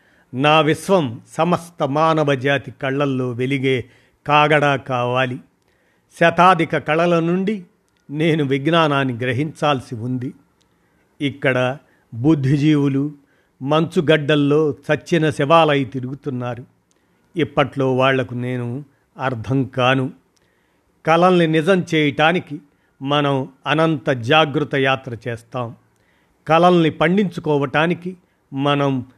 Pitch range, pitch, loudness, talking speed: 130-160 Hz, 145 Hz, -18 LUFS, 80 wpm